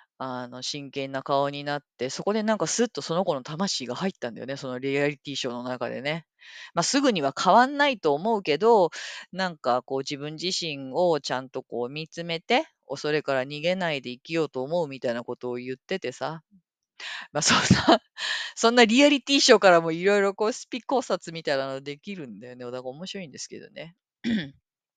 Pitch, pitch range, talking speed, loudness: 155 Hz, 135-200 Hz, 395 characters per minute, -25 LUFS